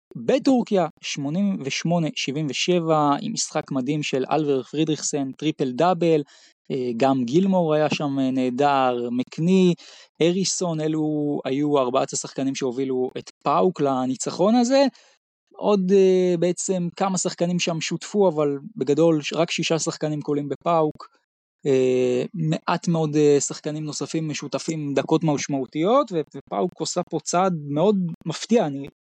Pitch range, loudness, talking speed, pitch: 140-175 Hz, -22 LUFS, 110 wpm, 155 Hz